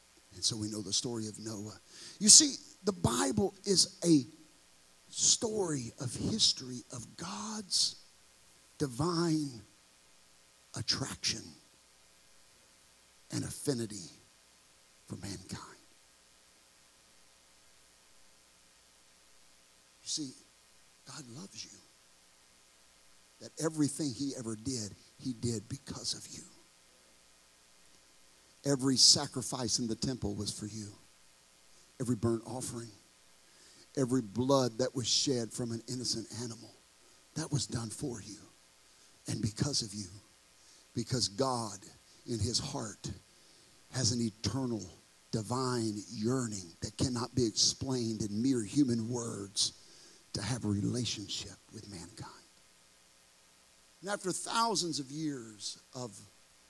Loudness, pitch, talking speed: -32 LUFS, 105 Hz, 105 wpm